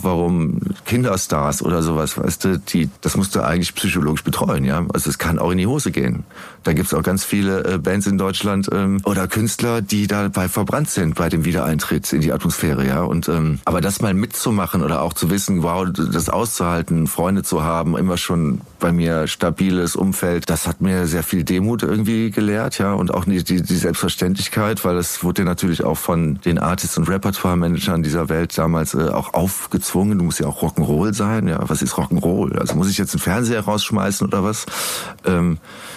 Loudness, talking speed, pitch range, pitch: -19 LUFS, 195 wpm, 85-100 Hz, 90 Hz